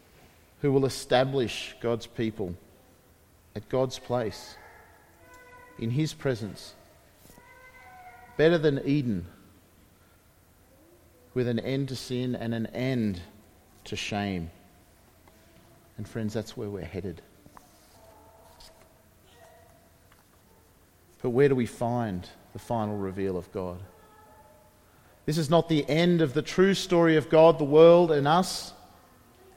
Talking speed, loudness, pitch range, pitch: 110 wpm, -26 LUFS, 95-145 Hz, 115 Hz